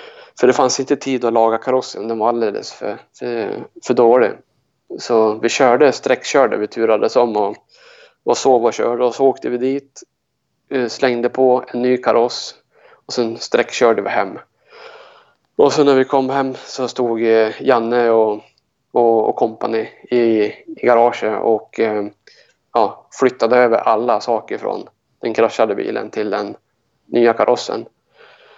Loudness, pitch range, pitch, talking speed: -16 LUFS, 115-140 Hz, 125 Hz, 150 wpm